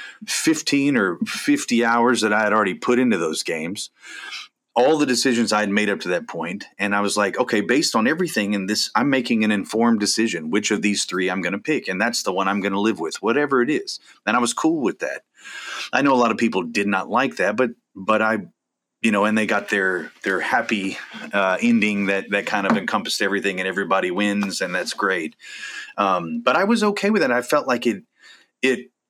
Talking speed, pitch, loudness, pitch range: 225 wpm, 110 Hz, -20 LUFS, 100-125 Hz